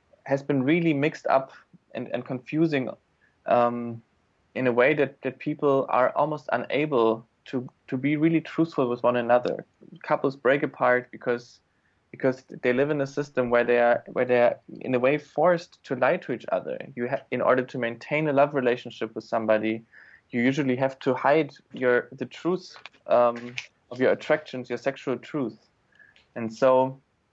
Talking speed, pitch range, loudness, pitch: 175 wpm, 120-145 Hz, -25 LUFS, 130 Hz